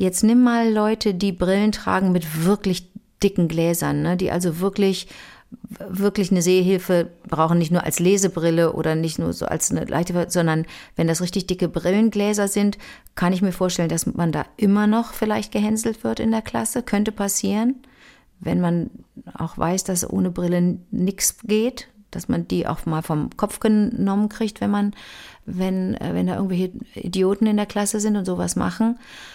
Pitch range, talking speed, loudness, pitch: 175-210 Hz, 175 wpm, -21 LUFS, 195 Hz